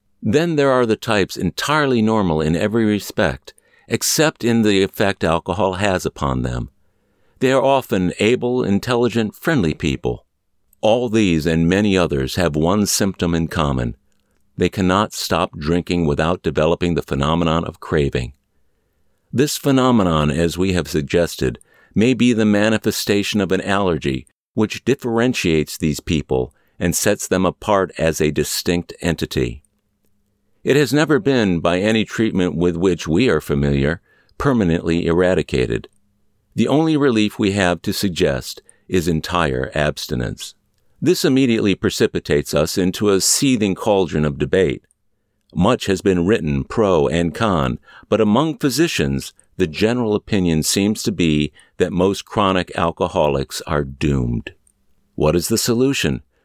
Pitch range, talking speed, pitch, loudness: 80-110 Hz, 140 wpm, 95 Hz, -18 LUFS